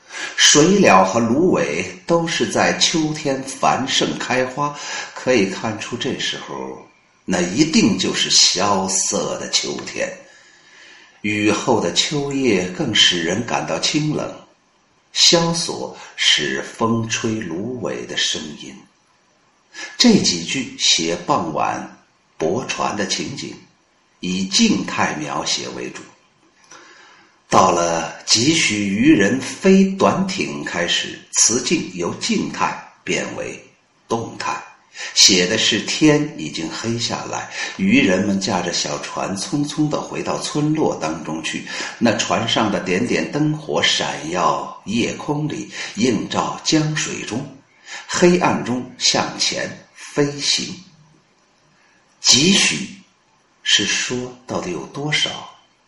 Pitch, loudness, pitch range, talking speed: 135 Hz, -18 LUFS, 105-155 Hz, 160 characters per minute